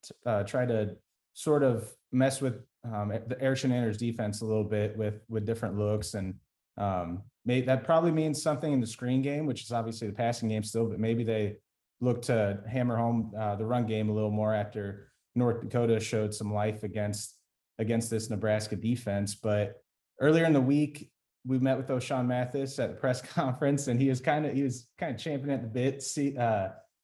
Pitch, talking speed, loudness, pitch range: 115 Hz, 200 wpm, -30 LUFS, 105-130 Hz